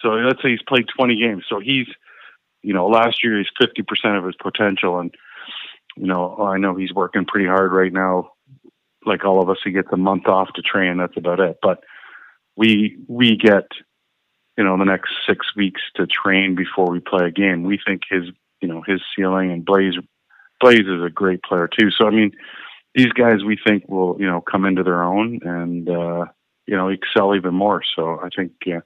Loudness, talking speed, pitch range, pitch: -18 LUFS, 210 wpm, 90-105 Hz, 95 Hz